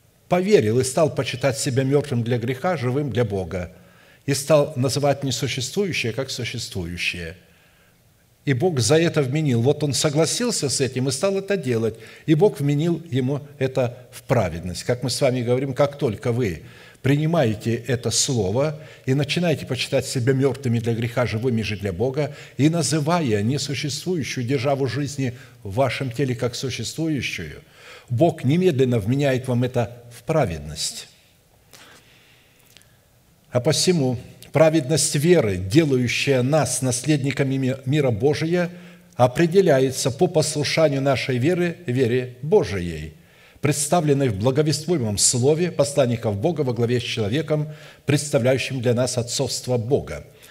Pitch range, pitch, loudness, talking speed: 125-150 Hz, 135 Hz, -21 LUFS, 130 wpm